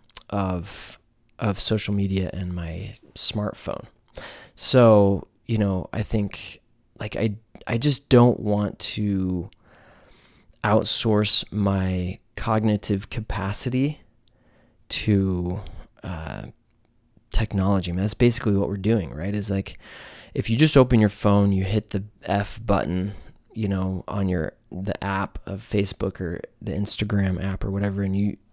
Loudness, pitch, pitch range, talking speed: -24 LUFS, 100 Hz, 95-110 Hz, 130 wpm